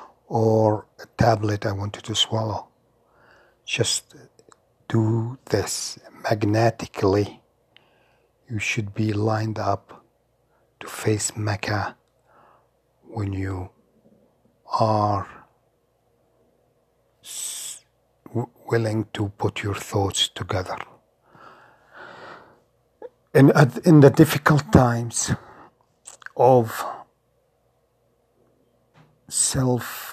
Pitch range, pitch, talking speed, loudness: 105-120 Hz, 110 Hz, 80 wpm, -22 LUFS